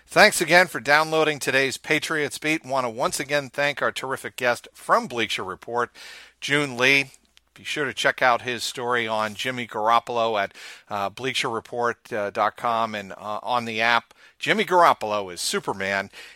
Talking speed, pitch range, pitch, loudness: 160 wpm, 115-145 Hz, 125 Hz, -23 LUFS